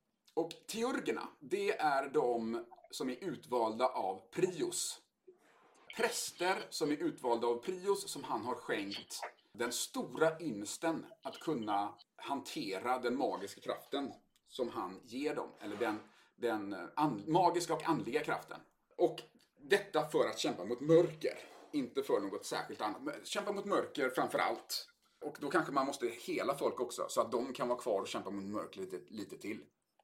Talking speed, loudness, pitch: 160 wpm, -37 LUFS, 200 Hz